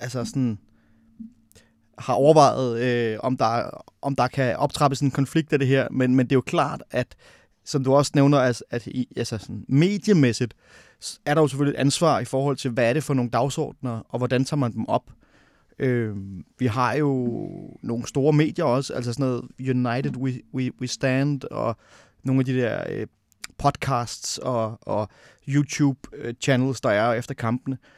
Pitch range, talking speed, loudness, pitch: 120-140 Hz, 185 wpm, -23 LUFS, 130 Hz